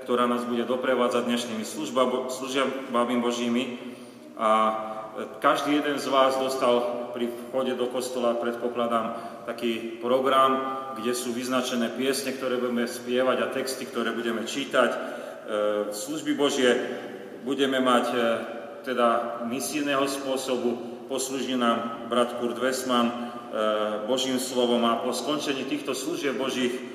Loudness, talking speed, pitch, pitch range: -26 LUFS, 115 wpm, 120 Hz, 120-130 Hz